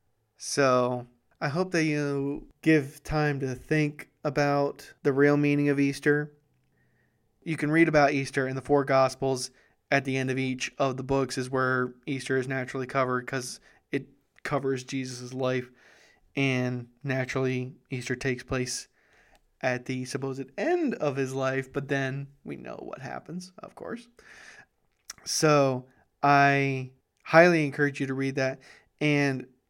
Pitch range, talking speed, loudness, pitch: 130-145 Hz, 145 wpm, -27 LUFS, 135 Hz